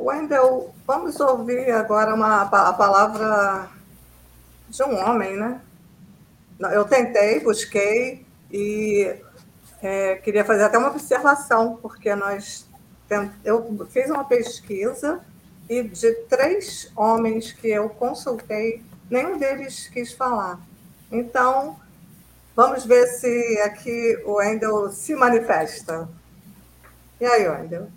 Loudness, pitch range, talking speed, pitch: -21 LUFS, 200-245 Hz, 105 wpm, 220 Hz